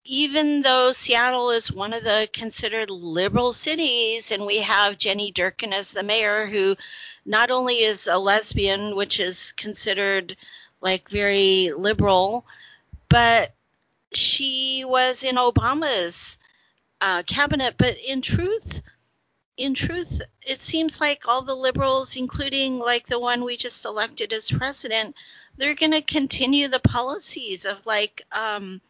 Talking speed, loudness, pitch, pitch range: 135 wpm, -22 LUFS, 235 Hz, 205-270 Hz